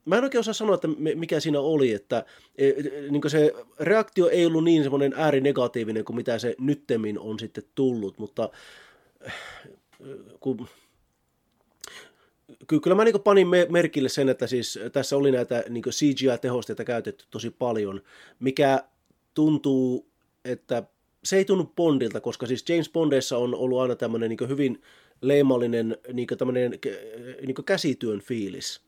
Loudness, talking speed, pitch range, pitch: -25 LUFS, 120 wpm, 120-155 Hz, 135 Hz